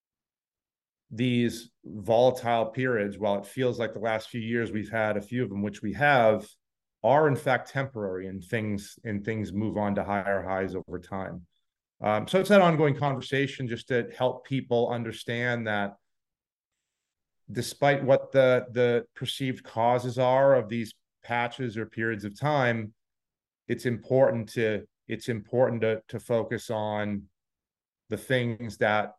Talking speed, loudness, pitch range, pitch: 150 wpm, -27 LUFS, 105-125 Hz, 115 Hz